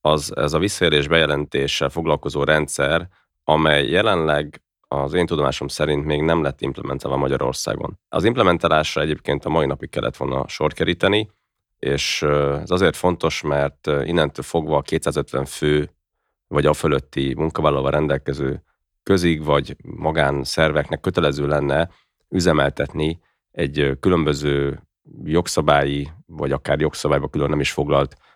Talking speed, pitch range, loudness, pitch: 125 wpm, 70-80 Hz, -20 LUFS, 75 Hz